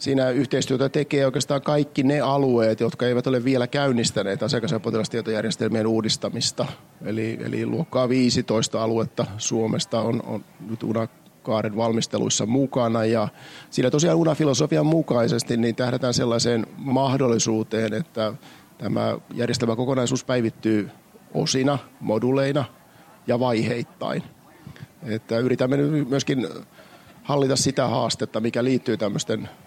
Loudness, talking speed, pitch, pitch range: -23 LUFS, 110 wpm, 120 Hz, 115-135 Hz